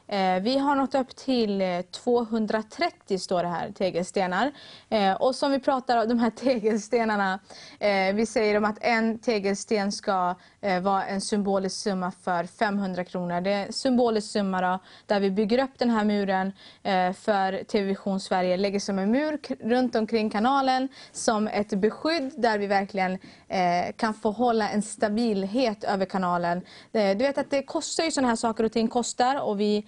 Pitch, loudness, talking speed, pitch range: 215 Hz, -26 LUFS, 165 wpm, 195-245 Hz